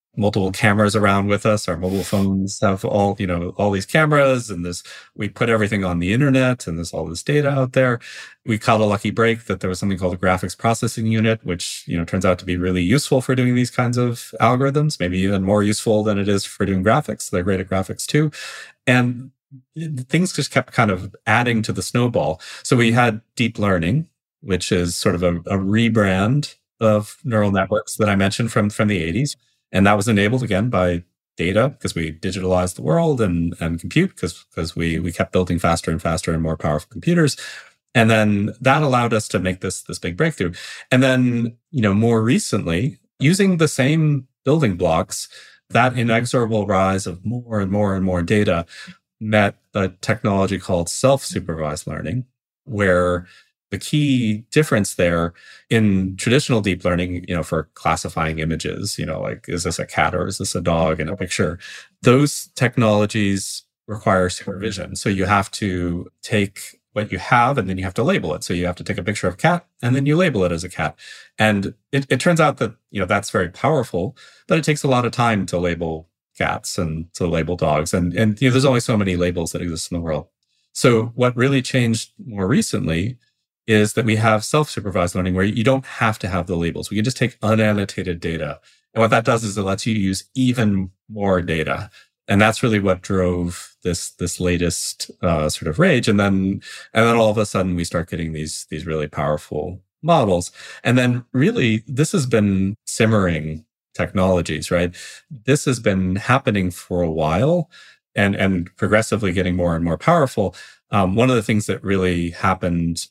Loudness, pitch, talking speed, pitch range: -19 LUFS, 105 Hz, 200 wpm, 90-120 Hz